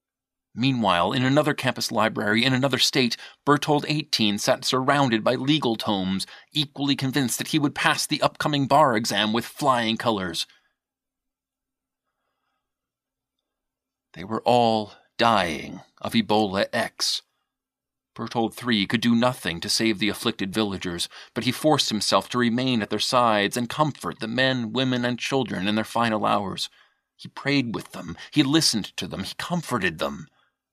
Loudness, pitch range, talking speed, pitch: -23 LUFS, 110-135 Hz, 150 wpm, 120 Hz